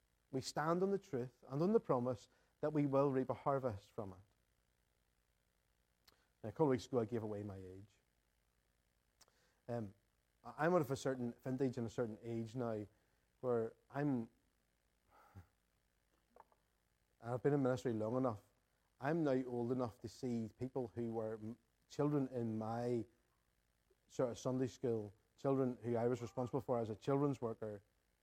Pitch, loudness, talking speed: 115 Hz, -41 LUFS, 160 wpm